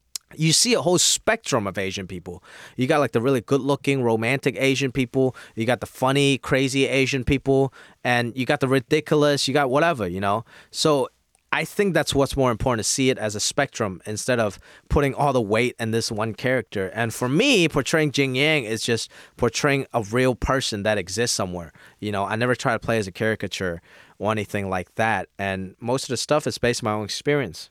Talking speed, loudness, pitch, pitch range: 210 wpm, -22 LUFS, 125 Hz, 110-140 Hz